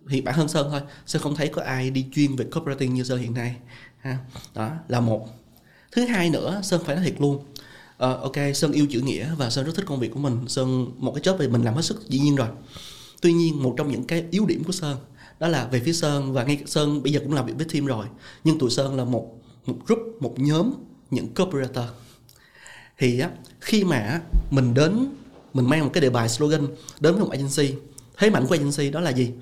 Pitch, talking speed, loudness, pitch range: 140 Hz, 240 wpm, -24 LUFS, 125-160 Hz